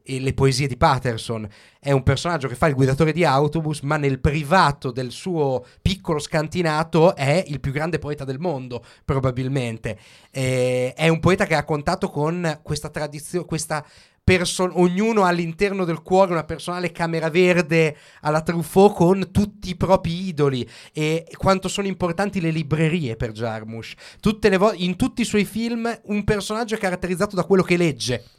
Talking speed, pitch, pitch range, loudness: 170 wpm, 160 Hz, 135-185 Hz, -21 LUFS